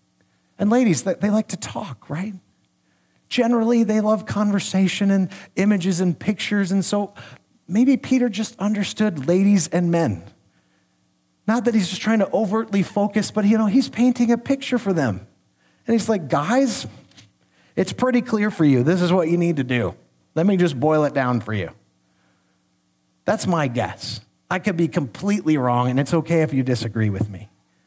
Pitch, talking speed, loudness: 185 Hz, 175 wpm, -21 LUFS